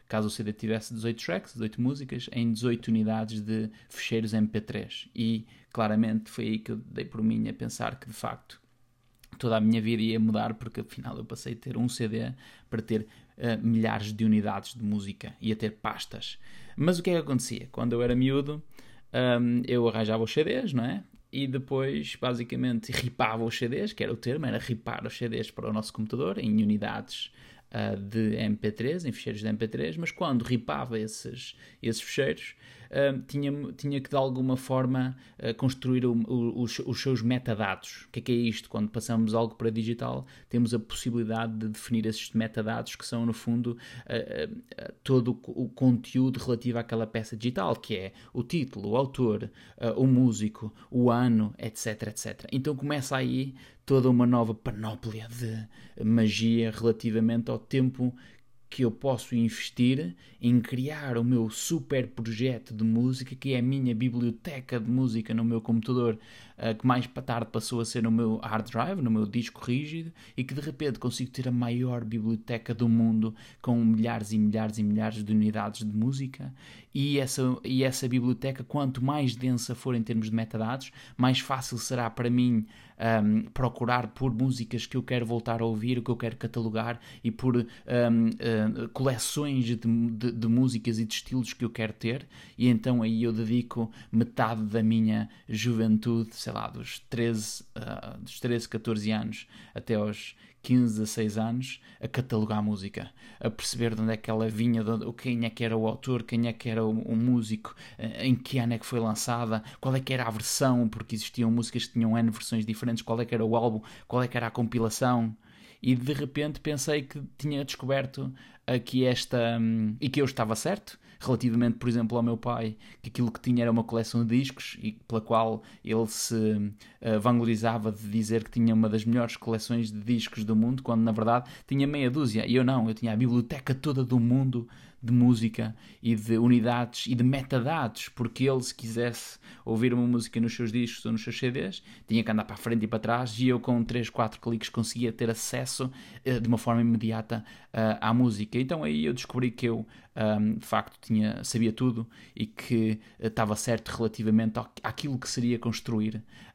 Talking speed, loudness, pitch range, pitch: 190 wpm, -29 LUFS, 110-125 Hz, 115 Hz